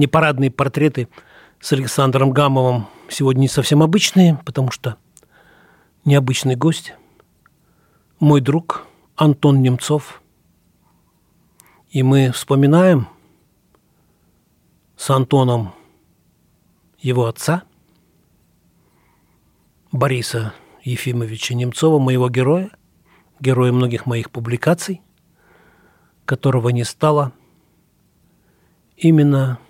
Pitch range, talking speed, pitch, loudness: 125-150 Hz, 75 wpm, 135 Hz, -17 LUFS